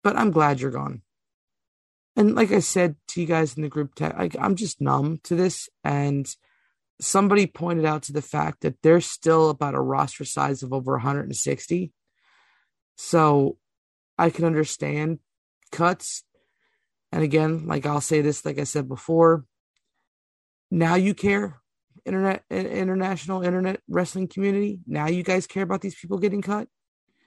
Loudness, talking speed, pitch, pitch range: -24 LUFS, 155 wpm, 160 Hz, 140-185 Hz